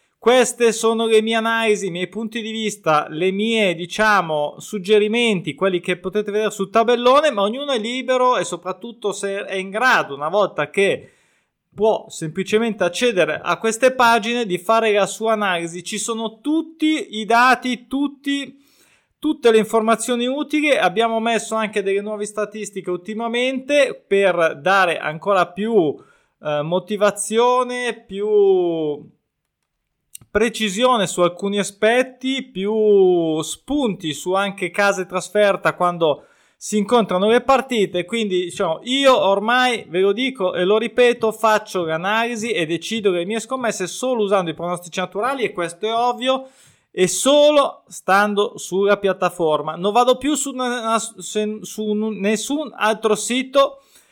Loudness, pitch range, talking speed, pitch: -19 LUFS, 190-240 Hz, 135 wpm, 215 Hz